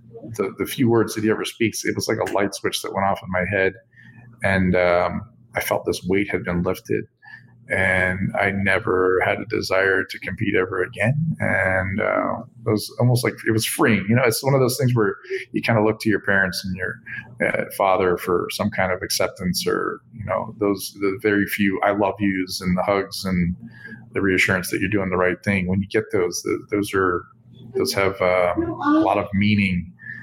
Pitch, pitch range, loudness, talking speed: 100 Hz, 95-110 Hz, -21 LUFS, 215 wpm